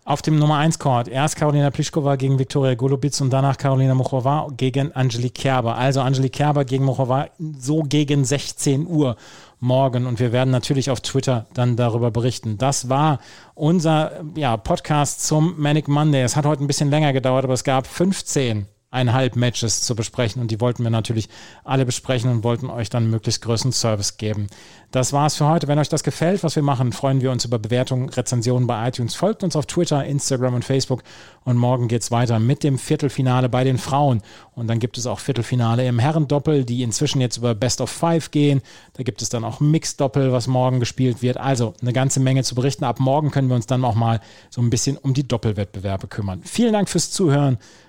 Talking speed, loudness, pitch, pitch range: 205 wpm, -20 LUFS, 130 Hz, 120-145 Hz